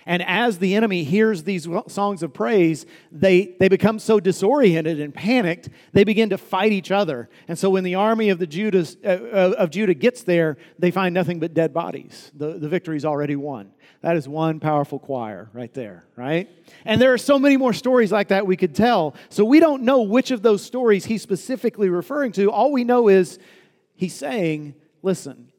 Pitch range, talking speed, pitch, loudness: 165-215 Hz, 200 wpm, 190 Hz, -20 LUFS